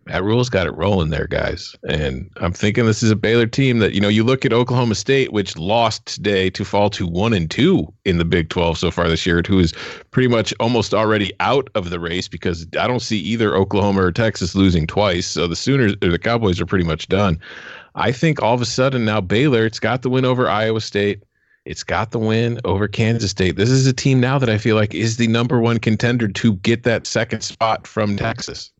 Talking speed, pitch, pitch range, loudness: 235 wpm, 110 Hz, 95-115 Hz, -18 LUFS